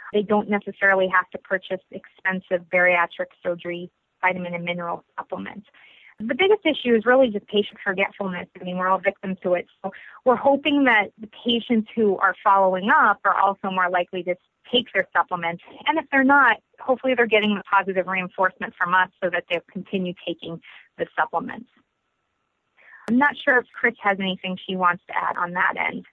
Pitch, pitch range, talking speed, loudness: 195 Hz, 185-235 Hz, 180 wpm, -22 LUFS